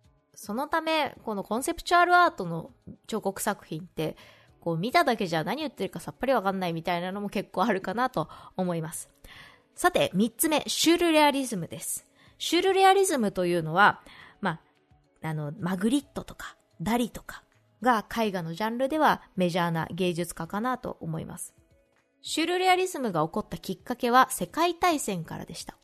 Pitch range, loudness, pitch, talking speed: 175-275 Hz, -27 LUFS, 210 Hz, 370 characters per minute